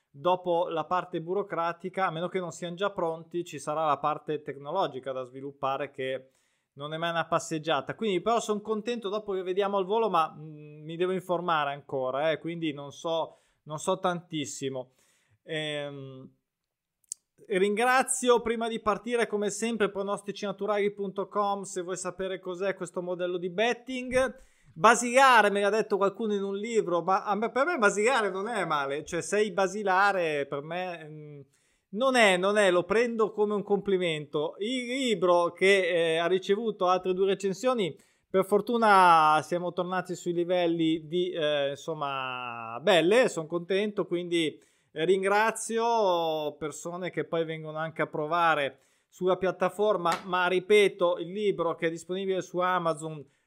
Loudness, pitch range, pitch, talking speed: -28 LUFS, 160-200 Hz, 180 Hz, 145 wpm